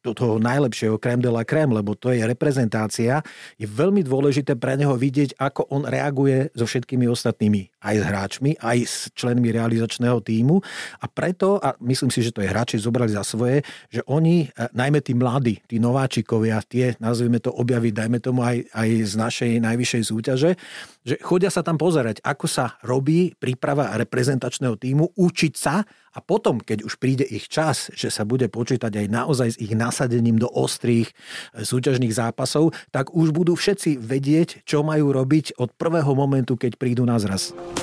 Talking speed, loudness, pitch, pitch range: 175 wpm, -22 LUFS, 125 Hz, 115-145 Hz